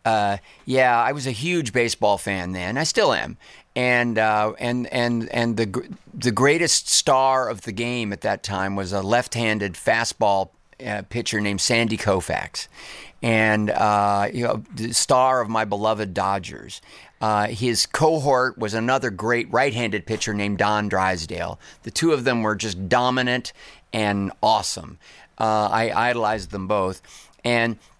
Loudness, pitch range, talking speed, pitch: -22 LUFS, 100-120 Hz, 155 wpm, 110 Hz